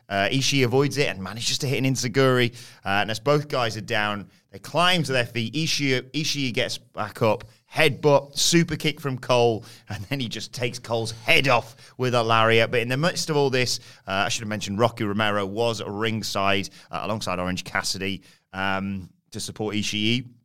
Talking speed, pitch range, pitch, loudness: 195 wpm, 105-135 Hz, 120 Hz, -23 LUFS